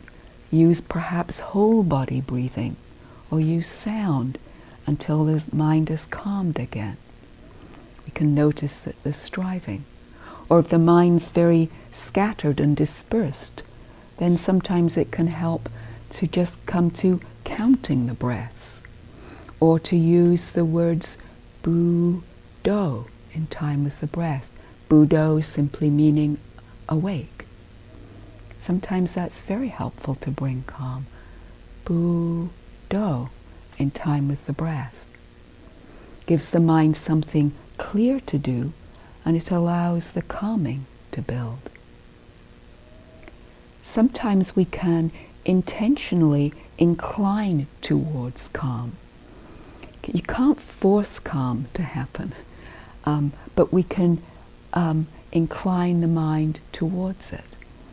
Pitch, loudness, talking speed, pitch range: 155 Hz, -23 LUFS, 110 wpm, 130-175 Hz